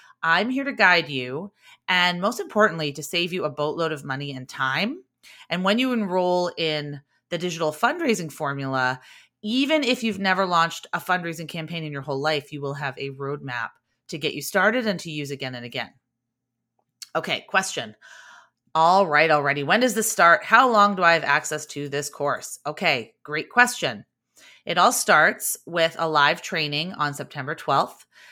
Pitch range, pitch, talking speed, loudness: 145-195 Hz, 165 Hz, 180 wpm, -22 LUFS